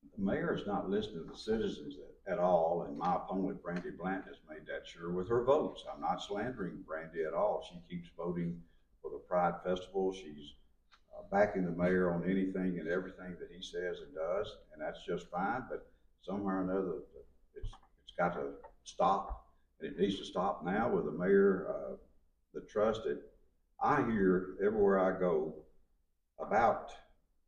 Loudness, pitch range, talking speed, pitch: -35 LUFS, 80-95 Hz, 175 wpm, 90 Hz